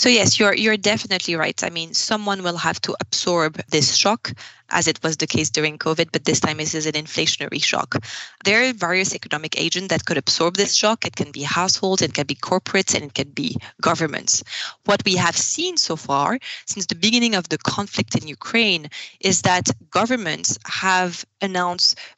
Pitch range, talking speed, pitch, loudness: 160-200 Hz, 195 wpm, 180 Hz, -20 LUFS